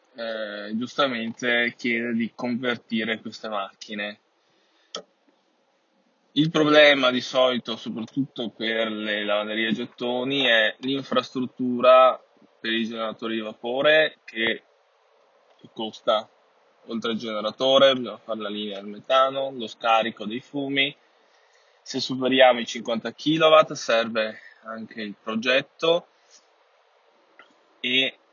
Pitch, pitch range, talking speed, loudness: 120 Hz, 110-135 Hz, 105 wpm, -23 LUFS